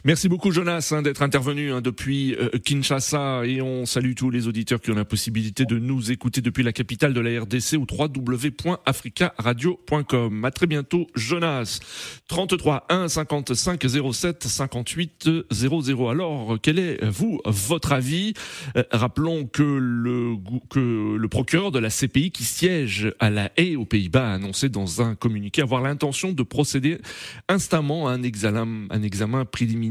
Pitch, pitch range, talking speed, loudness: 130 Hz, 120-150 Hz, 160 wpm, -23 LUFS